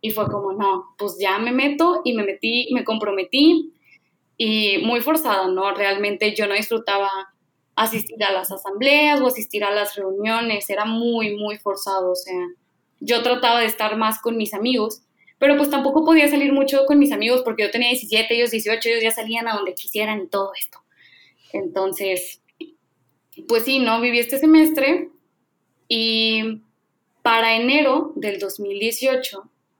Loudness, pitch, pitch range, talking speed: -19 LUFS, 225 Hz, 200-250 Hz, 160 wpm